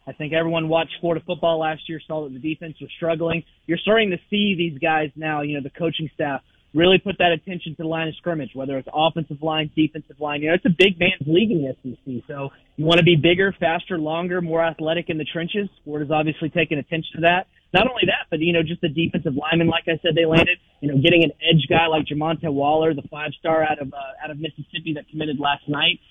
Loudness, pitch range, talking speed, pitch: -21 LUFS, 150-170 Hz, 245 wpm, 160 Hz